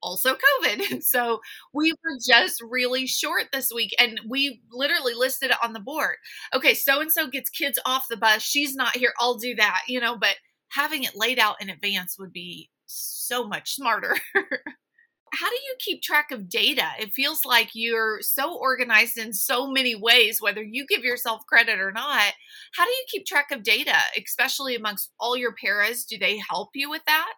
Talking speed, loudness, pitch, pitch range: 195 wpm, -22 LUFS, 245 Hz, 225-280 Hz